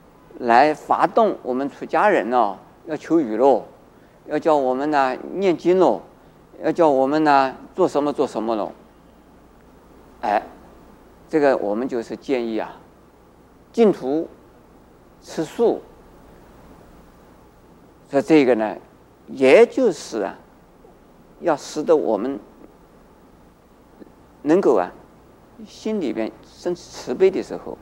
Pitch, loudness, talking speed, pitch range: 145 Hz, -20 LUFS, 155 characters per minute, 130-175 Hz